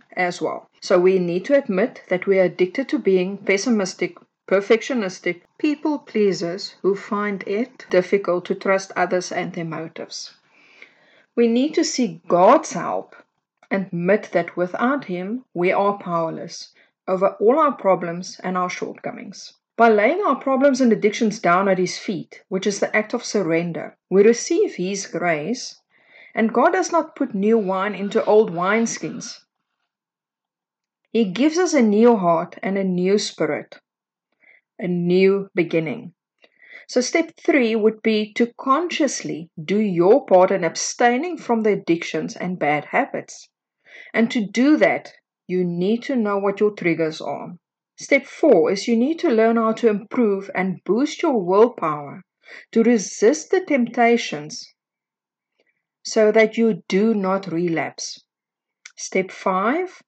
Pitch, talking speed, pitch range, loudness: 210 Hz, 150 wpm, 185-240 Hz, -20 LUFS